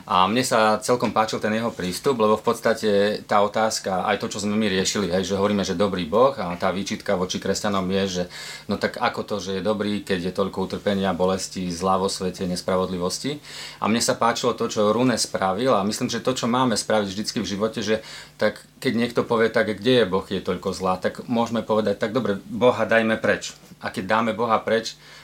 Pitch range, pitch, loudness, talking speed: 95-110 Hz, 105 Hz, -23 LUFS, 215 wpm